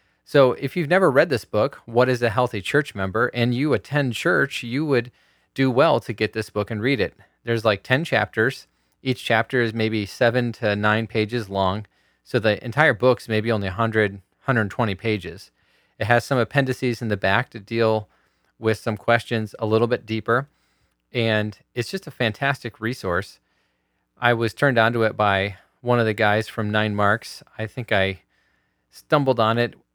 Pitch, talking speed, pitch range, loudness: 115 Hz, 180 wpm, 105-125 Hz, -22 LUFS